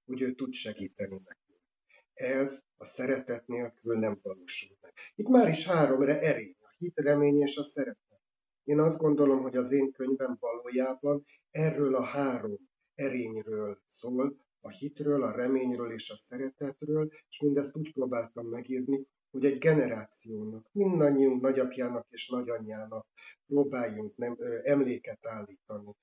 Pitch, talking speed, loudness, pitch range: 130 Hz, 140 wpm, -31 LUFS, 120-145 Hz